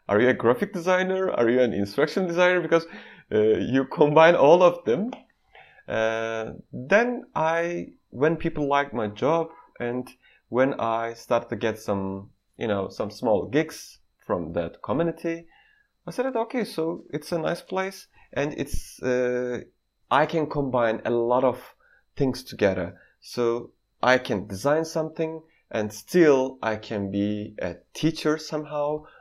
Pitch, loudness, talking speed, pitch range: 140 Hz, -25 LUFS, 150 wpm, 120-165 Hz